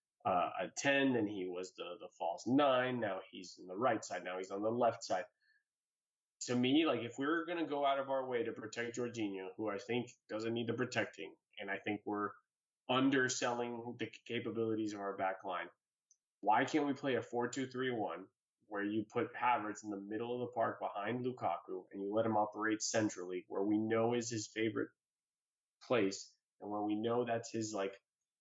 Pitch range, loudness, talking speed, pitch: 105-120 Hz, -38 LUFS, 205 wpm, 115 Hz